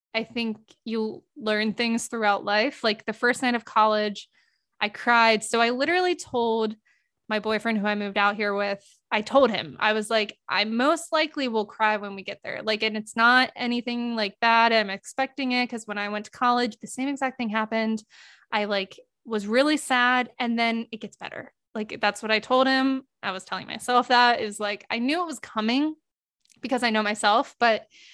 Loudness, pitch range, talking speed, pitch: -24 LUFS, 215-250 Hz, 205 wpm, 230 Hz